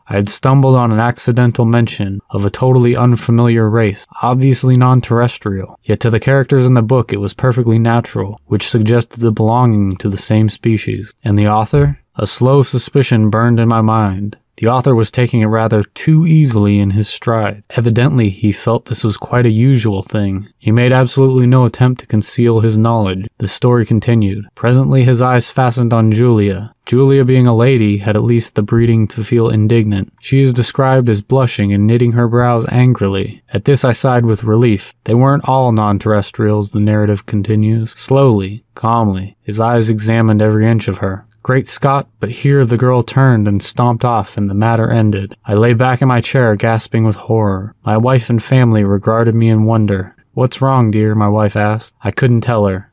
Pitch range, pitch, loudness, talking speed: 105-125 Hz, 115 Hz, -12 LUFS, 190 wpm